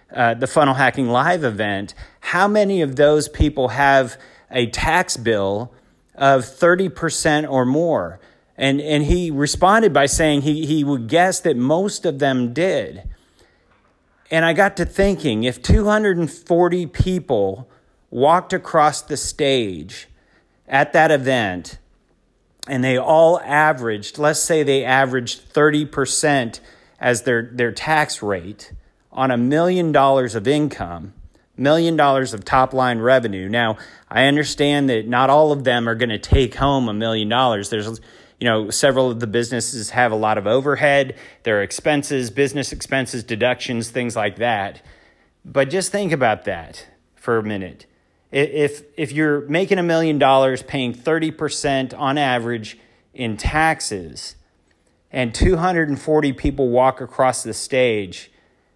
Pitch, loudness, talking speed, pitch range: 135 Hz, -18 LUFS, 145 wpm, 120-150 Hz